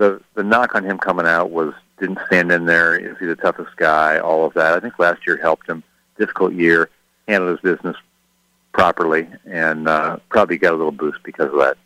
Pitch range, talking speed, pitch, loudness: 80-90 Hz, 215 wpm, 85 Hz, -17 LUFS